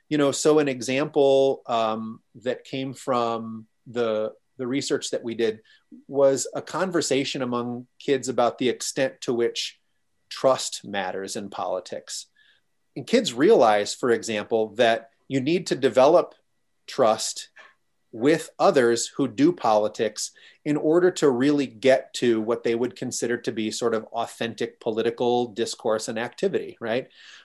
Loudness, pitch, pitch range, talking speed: -24 LUFS, 120 Hz, 115-140 Hz, 140 wpm